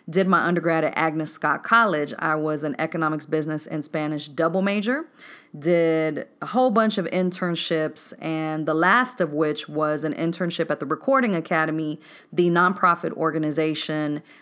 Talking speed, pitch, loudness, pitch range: 155 wpm, 160 Hz, -23 LUFS, 155-180 Hz